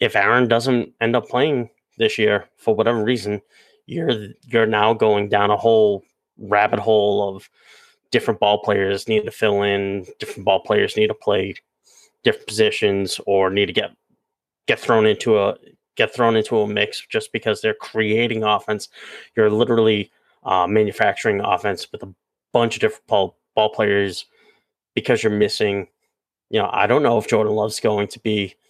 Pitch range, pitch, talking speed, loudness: 105-115 Hz, 110 Hz, 170 wpm, -19 LUFS